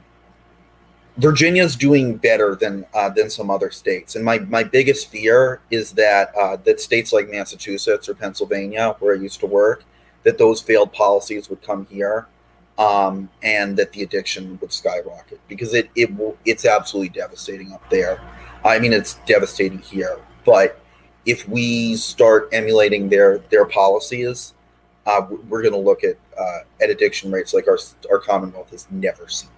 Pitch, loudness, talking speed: 135 Hz, -18 LUFS, 165 wpm